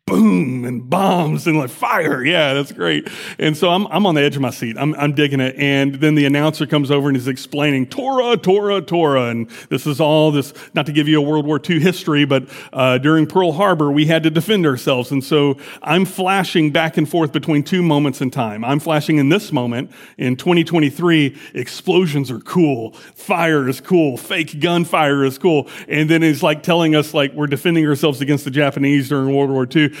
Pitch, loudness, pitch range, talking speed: 150 Hz, -16 LUFS, 140-165 Hz, 210 wpm